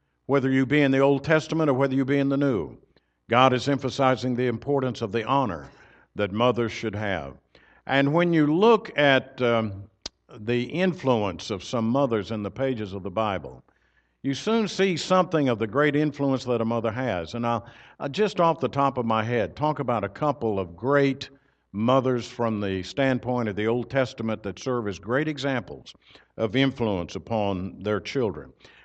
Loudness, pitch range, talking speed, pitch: -25 LUFS, 110-140 Hz, 185 wpm, 125 Hz